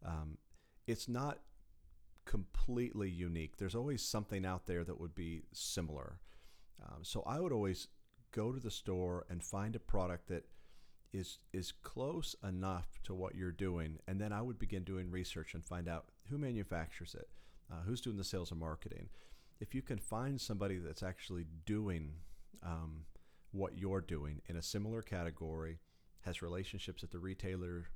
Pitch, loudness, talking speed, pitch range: 90 Hz, -44 LUFS, 165 wpm, 85-105 Hz